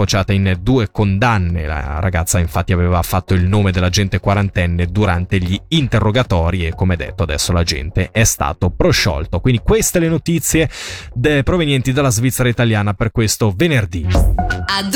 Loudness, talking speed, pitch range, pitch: -16 LUFS, 140 wpm, 90-120 Hz, 100 Hz